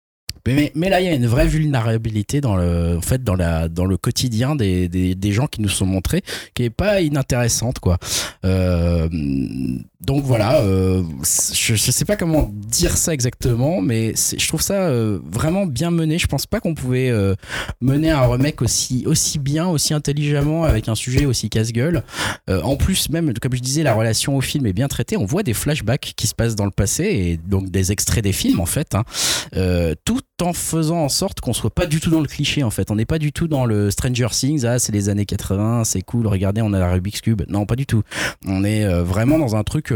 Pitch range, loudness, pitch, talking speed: 100-145 Hz, -19 LUFS, 115 Hz, 230 wpm